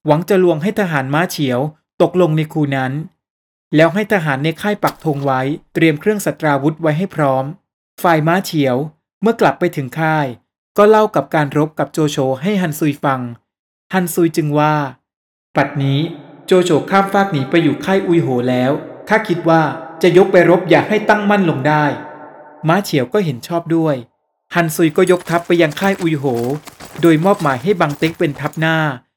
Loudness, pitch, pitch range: -15 LUFS, 160 Hz, 145-175 Hz